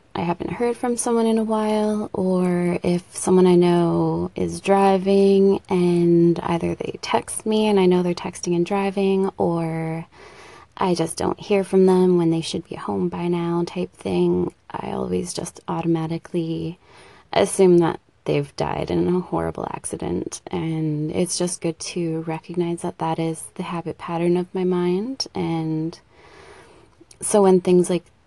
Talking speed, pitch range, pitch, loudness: 160 wpm, 165-195 Hz, 175 Hz, -21 LUFS